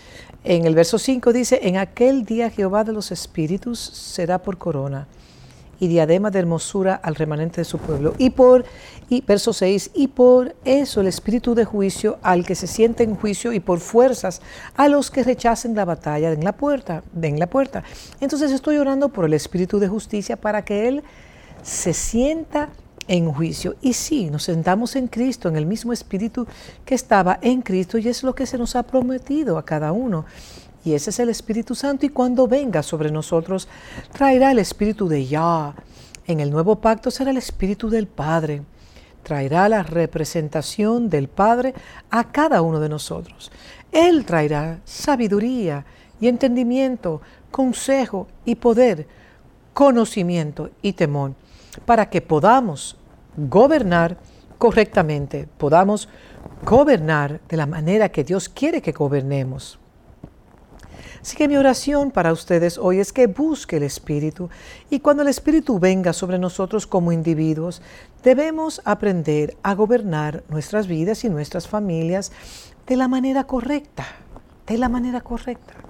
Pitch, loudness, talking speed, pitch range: 205 Hz, -20 LUFS, 155 wpm, 165-250 Hz